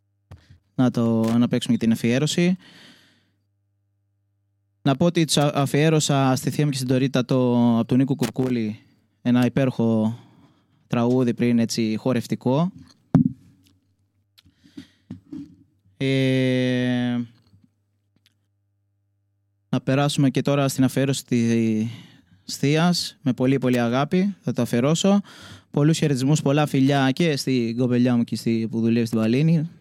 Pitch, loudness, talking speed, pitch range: 125 Hz, -21 LUFS, 120 wpm, 110-135 Hz